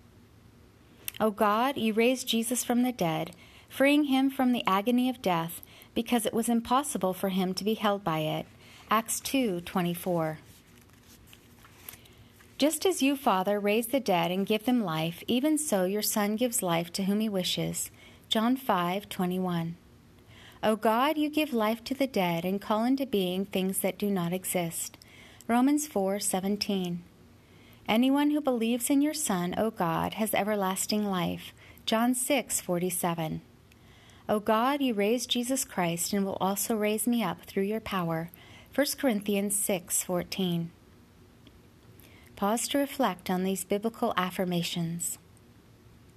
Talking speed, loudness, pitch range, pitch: 145 wpm, -29 LUFS, 170-235 Hz, 195 Hz